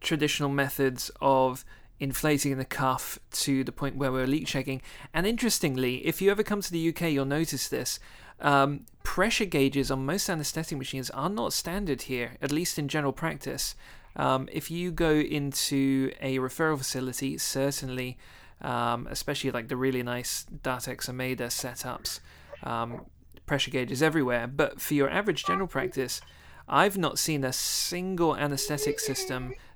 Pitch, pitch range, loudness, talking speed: 140 Hz, 130-155 Hz, -29 LUFS, 155 wpm